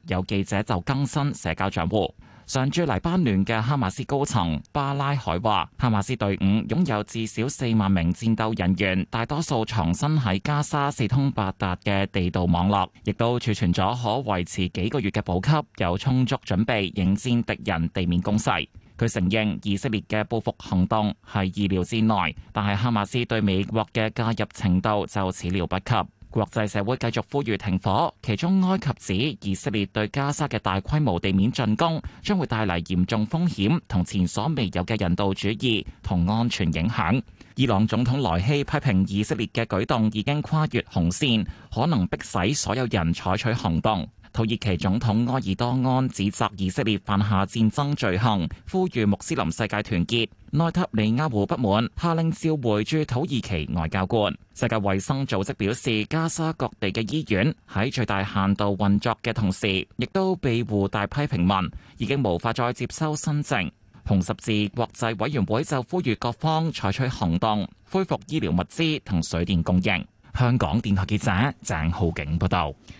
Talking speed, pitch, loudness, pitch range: 270 characters per minute, 110 Hz, -24 LUFS, 95-130 Hz